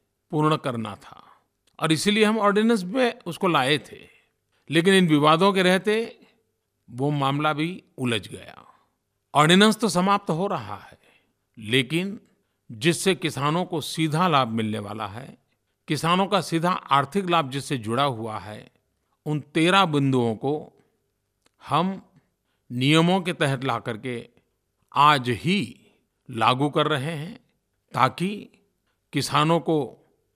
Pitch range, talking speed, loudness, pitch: 130-185 Hz, 125 wpm, -23 LUFS, 155 Hz